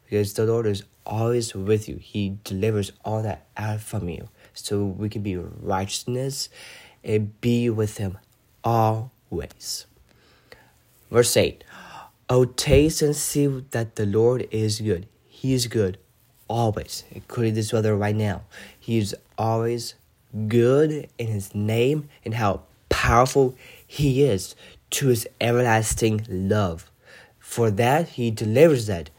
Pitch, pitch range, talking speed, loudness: 110 Hz, 105-120 Hz, 135 wpm, -23 LUFS